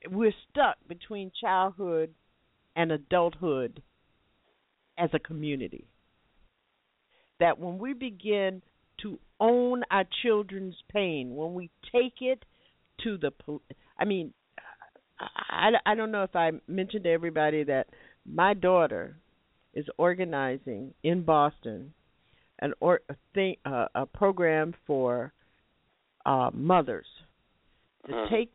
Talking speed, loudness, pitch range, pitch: 115 wpm, -29 LUFS, 155-200 Hz, 175 Hz